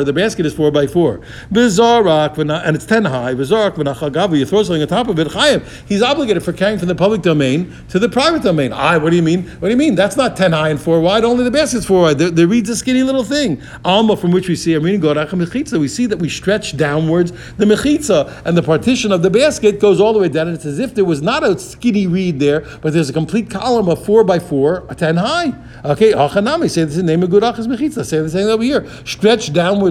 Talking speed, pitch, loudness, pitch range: 240 wpm, 185 Hz, -14 LUFS, 160-225 Hz